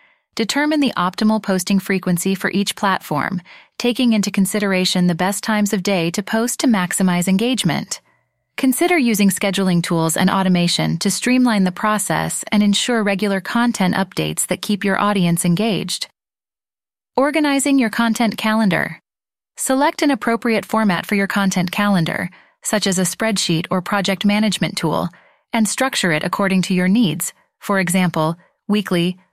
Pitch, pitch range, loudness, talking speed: 200 Hz, 185-225 Hz, -18 LUFS, 145 wpm